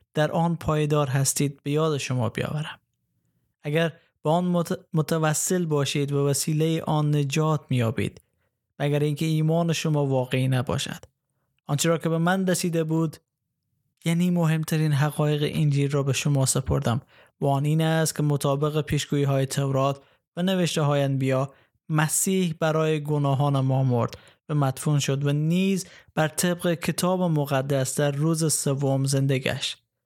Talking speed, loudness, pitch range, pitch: 140 wpm, -24 LUFS, 140-160 Hz, 150 Hz